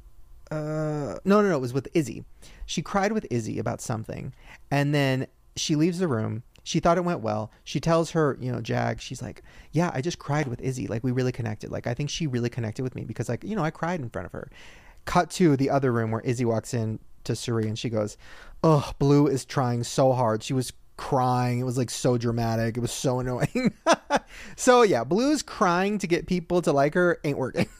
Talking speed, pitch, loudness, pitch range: 225 wpm, 130 Hz, -26 LUFS, 120-160 Hz